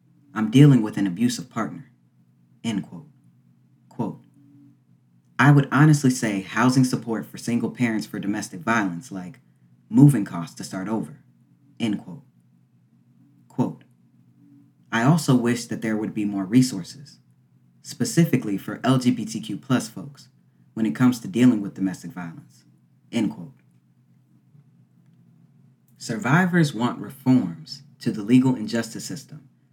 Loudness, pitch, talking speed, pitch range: -22 LUFS, 115 Hz, 125 wpm, 85-130 Hz